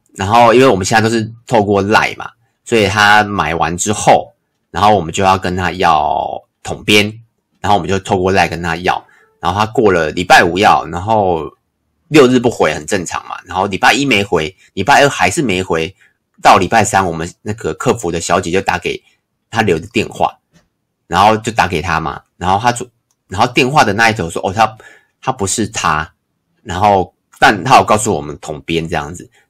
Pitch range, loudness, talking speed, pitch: 90-110 Hz, -13 LUFS, 280 characters per minute, 100 Hz